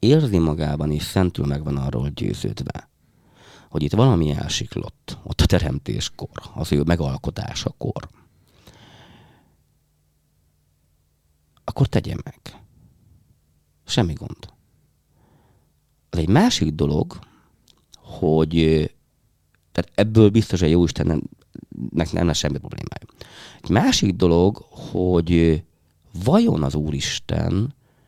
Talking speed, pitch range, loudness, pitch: 95 wpm, 75-90 Hz, -21 LUFS, 80 Hz